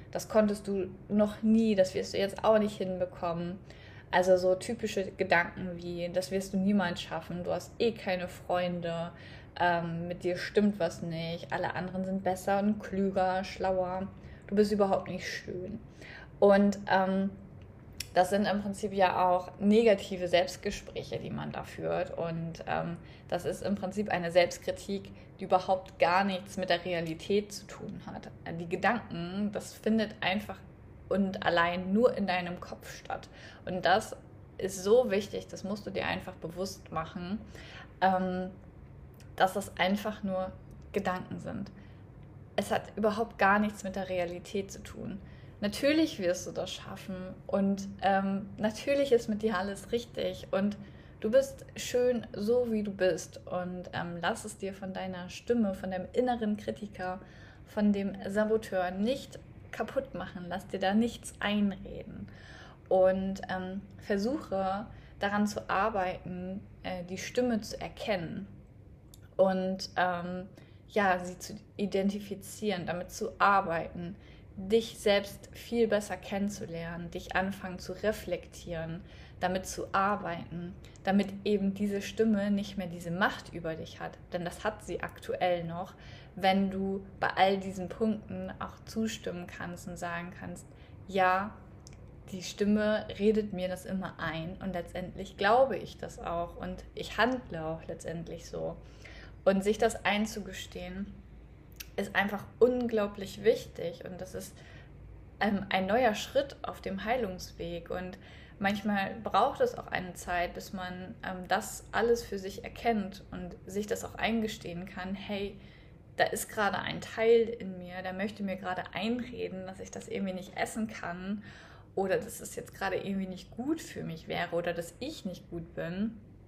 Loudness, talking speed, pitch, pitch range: -32 LUFS, 150 wpm, 190 Hz, 180-205 Hz